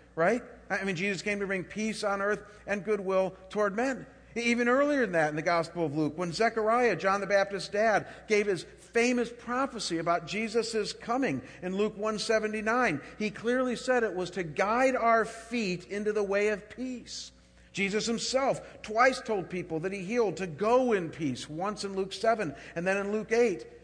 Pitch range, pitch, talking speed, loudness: 190-230 Hz, 210 Hz, 185 wpm, -29 LUFS